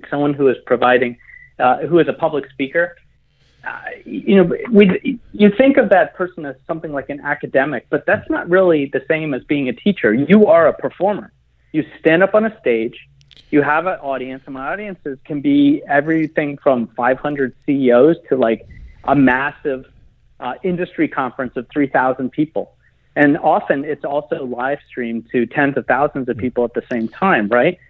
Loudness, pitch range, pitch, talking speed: -17 LUFS, 130-170 Hz, 145 Hz, 180 wpm